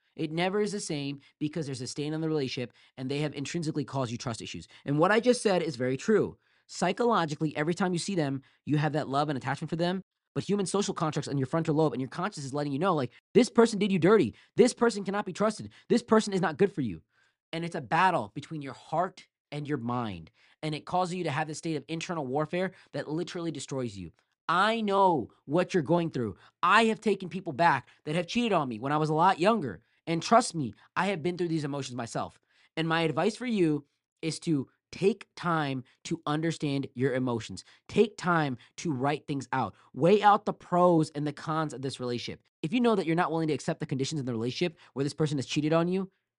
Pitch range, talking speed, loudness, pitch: 140-180 Hz, 235 wpm, -29 LUFS, 160 Hz